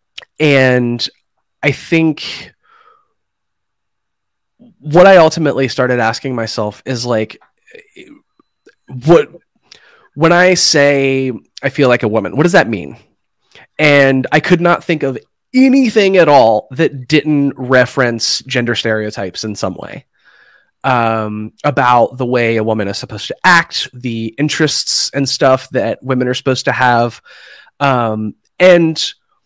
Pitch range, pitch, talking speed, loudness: 120-165 Hz, 135 Hz, 130 wpm, -12 LUFS